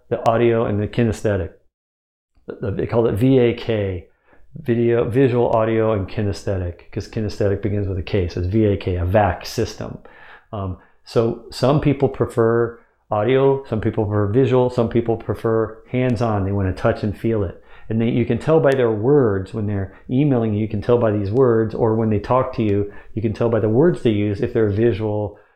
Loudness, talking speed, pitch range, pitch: -19 LUFS, 195 wpm, 105-120 Hz, 110 Hz